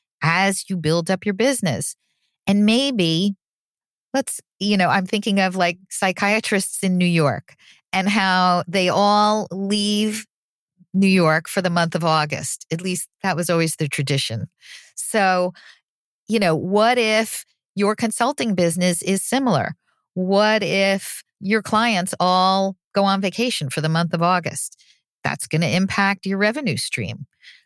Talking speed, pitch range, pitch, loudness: 150 wpm, 175-210 Hz, 190 Hz, -20 LUFS